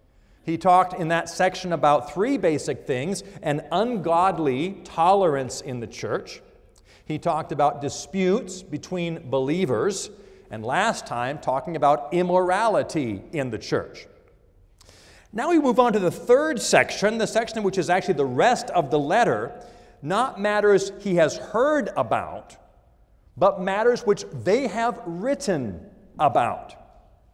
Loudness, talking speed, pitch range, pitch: -23 LUFS, 135 wpm, 155-215 Hz, 185 Hz